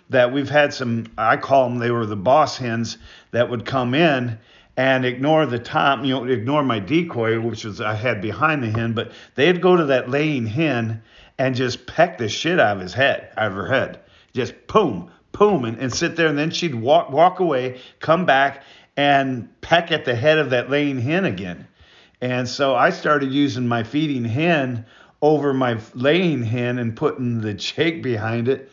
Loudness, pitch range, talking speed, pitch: -20 LUFS, 115-150 Hz, 200 wpm, 130 Hz